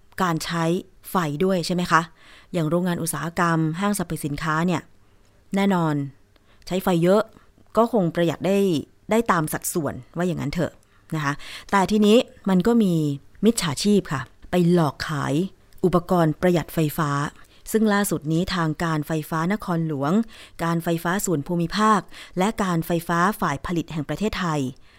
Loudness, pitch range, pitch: -23 LUFS, 155-185 Hz, 170 Hz